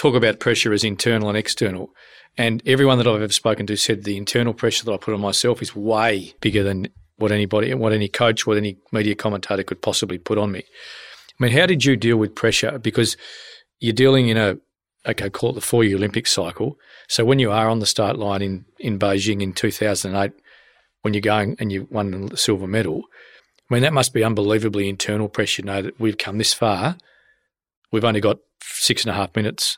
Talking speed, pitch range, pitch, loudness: 215 wpm, 100-115 Hz, 105 Hz, -20 LUFS